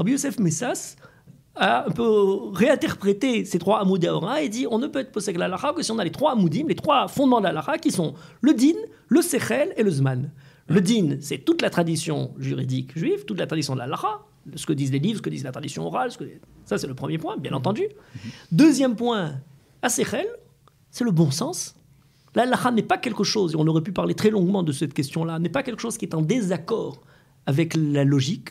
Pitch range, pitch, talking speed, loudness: 155-240 Hz, 190 Hz, 220 wpm, -23 LUFS